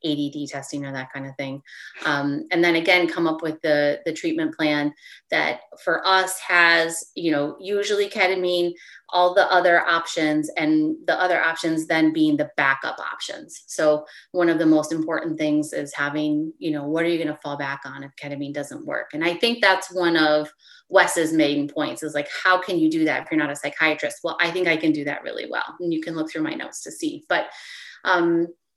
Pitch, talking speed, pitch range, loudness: 160 Hz, 215 wpm, 150-180 Hz, -22 LUFS